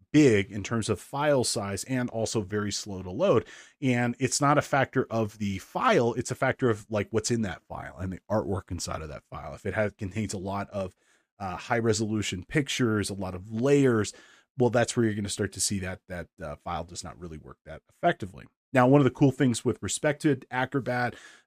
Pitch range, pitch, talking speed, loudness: 100-125 Hz, 110 Hz, 225 wpm, -27 LUFS